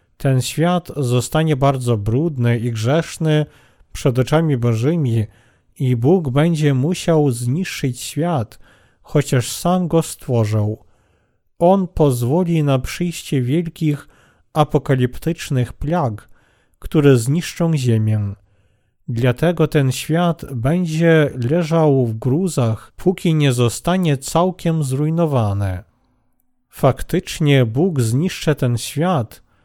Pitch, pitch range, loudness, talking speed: 135 Hz, 120-160 Hz, -18 LUFS, 95 wpm